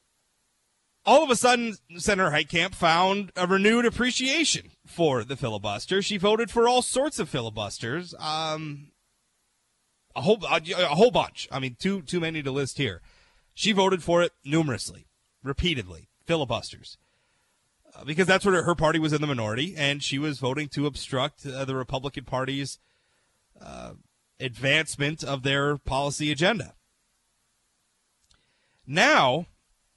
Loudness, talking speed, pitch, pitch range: -25 LUFS, 140 wpm, 155 Hz, 135-190 Hz